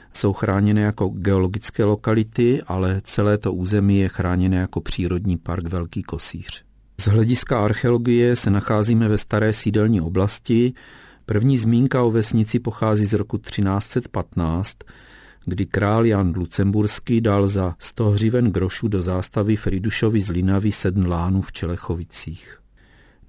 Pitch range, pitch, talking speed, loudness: 95-110 Hz, 105 Hz, 130 wpm, -20 LUFS